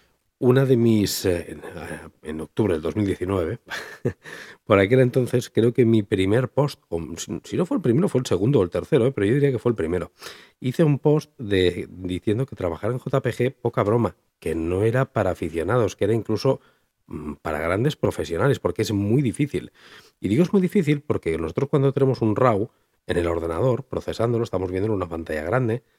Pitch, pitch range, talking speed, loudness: 115 Hz, 95-130 Hz, 185 wpm, -23 LUFS